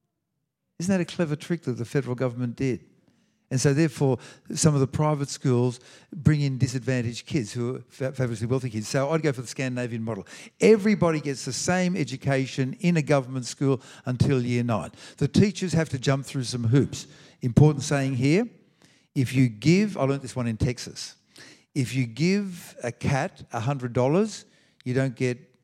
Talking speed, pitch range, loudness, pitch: 175 wpm, 125-160 Hz, -25 LUFS, 135 Hz